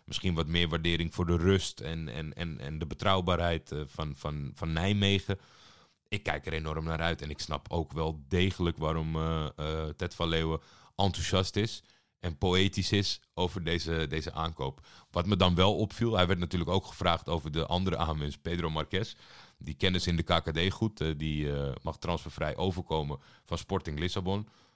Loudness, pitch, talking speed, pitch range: -31 LUFS, 85 Hz, 185 wpm, 80-95 Hz